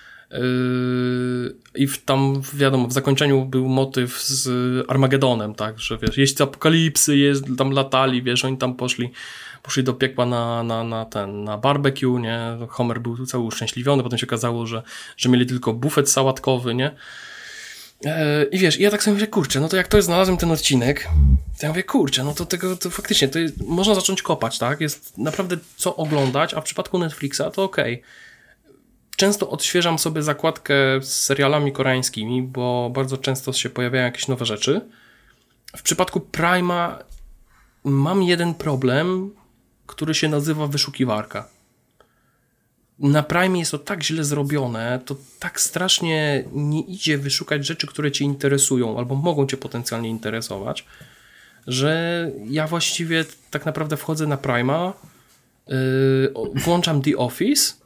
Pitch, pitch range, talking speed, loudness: 140 Hz, 125-160 Hz, 155 wpm, -21 LUFS